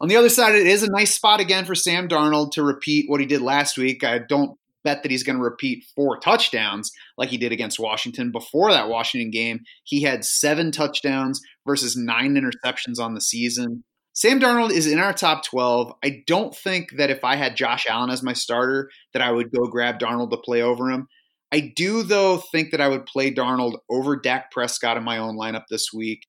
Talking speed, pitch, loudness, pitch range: 220 wpm, 135 Hz, -21 LUFS, 120-155 Hz